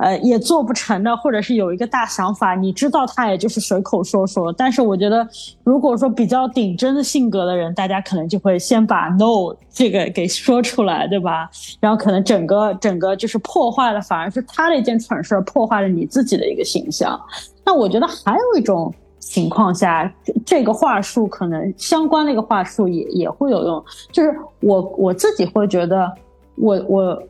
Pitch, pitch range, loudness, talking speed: 215 Hz, 190-250 Hz, -17 LUFS, 295 characters per minute